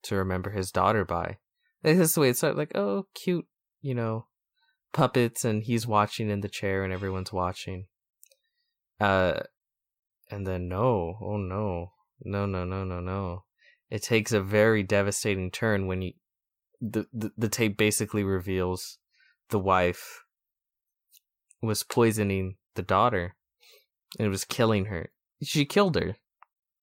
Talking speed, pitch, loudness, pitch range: 145 wpm, 105 Hz, -28 LUFS, 95-115 Hz